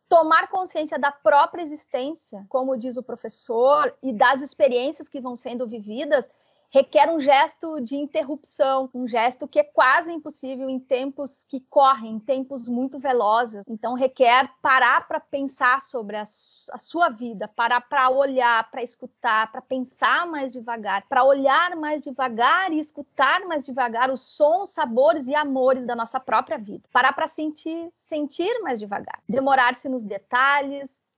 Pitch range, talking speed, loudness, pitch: 250-300 Hz, 155 wpm, -22 LUFS, 270 Hz